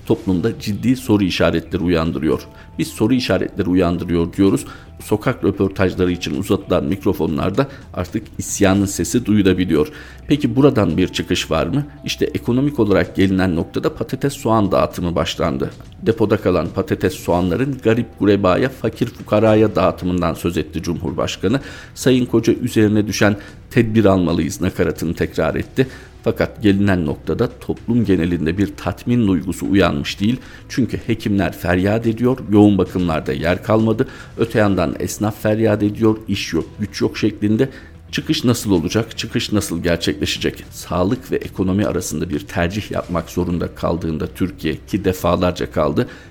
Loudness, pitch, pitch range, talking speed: -18 LUFS, 100 Hz, 85-110 Hz, 130 wpm